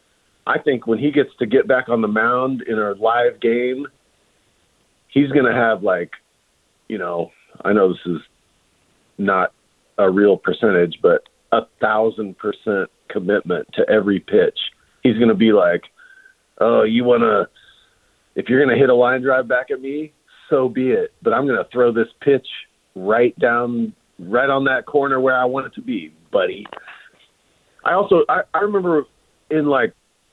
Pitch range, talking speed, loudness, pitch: 115-150 Hz, 175 wpm, -18 LUFS, 130 Hz